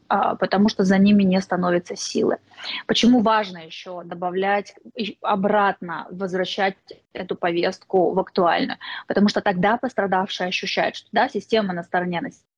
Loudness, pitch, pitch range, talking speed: -21 LUFS, 195 Hz, 180-205 Hz, 140 wpm